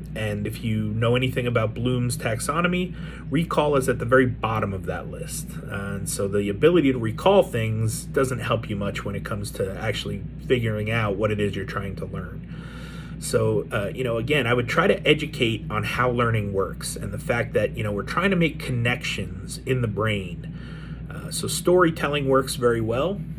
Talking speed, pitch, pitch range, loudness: 195 wpm, 125 Hz, 110-155 Hz, -24 LUFS